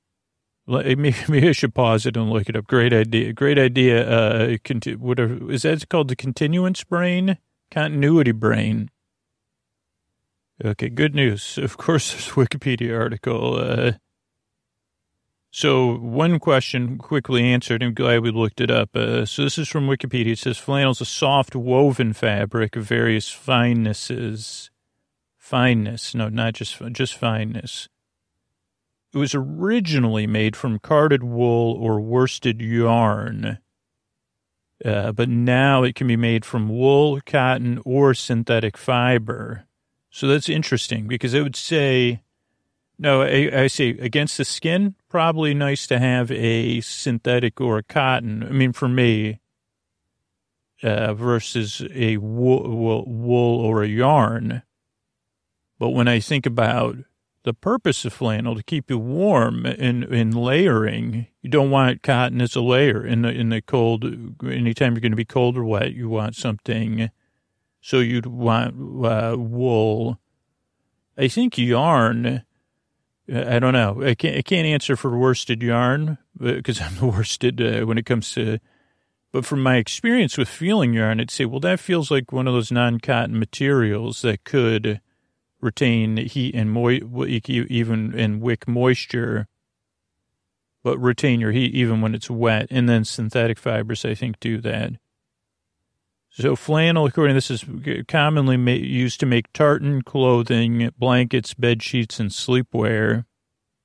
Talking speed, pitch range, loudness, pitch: 150 wpm, 115-130 Hz, -20 LUFS, 120 Hz